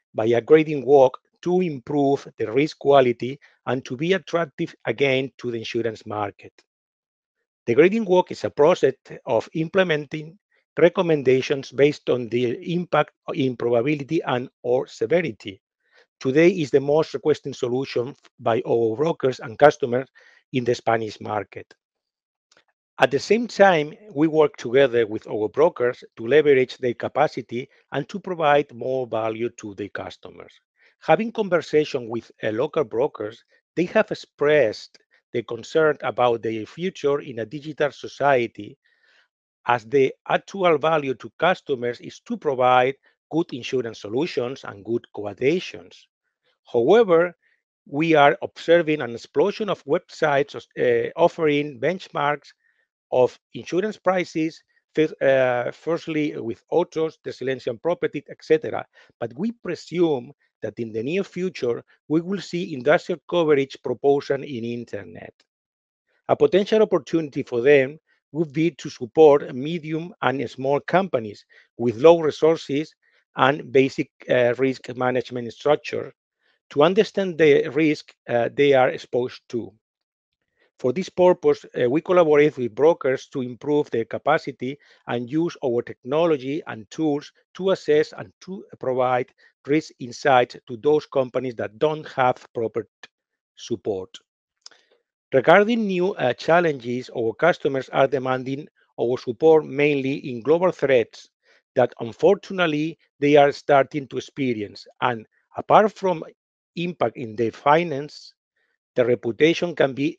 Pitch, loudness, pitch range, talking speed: 145 Hz, -22 LUFS, 125-170 Hz, 130 wpm